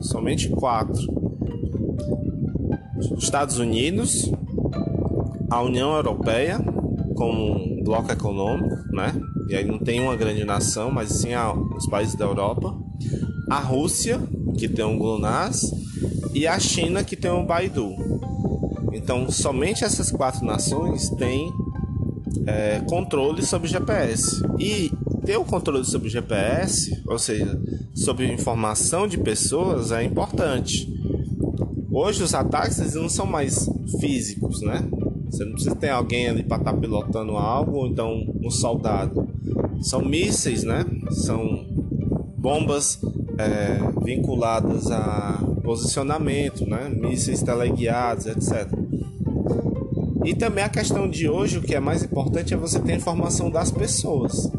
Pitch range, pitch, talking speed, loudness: 105-120 Hz, 115 Hz, 130 wpm, -24 LUFS